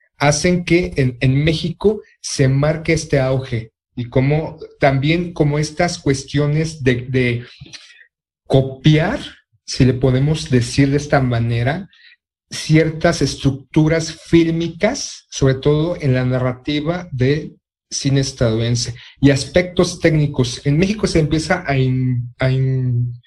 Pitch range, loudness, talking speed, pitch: 130-165 Hz, -17 LUFS, 120 wpm, 145 Hz